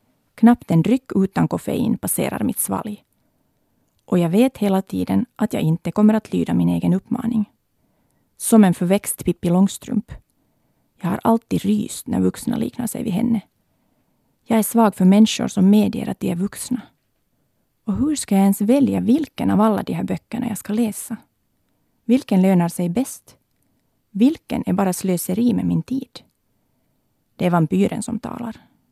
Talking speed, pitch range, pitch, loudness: 165 wpm, 185-230 Hz, 210 Hz, -19 LUFS